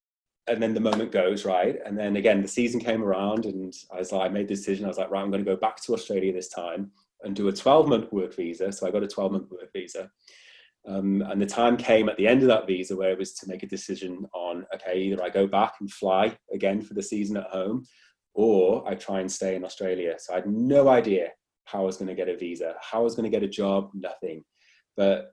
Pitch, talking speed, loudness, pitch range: 100 Hz, 265 wpm, -26 LUFS, 95-105 Hz